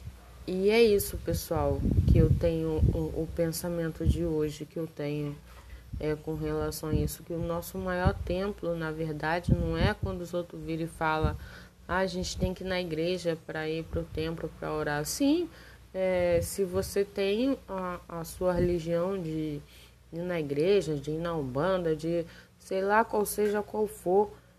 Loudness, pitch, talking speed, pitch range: -30 LUFS, 170 Hz, 180 wpm, 155-185 Hz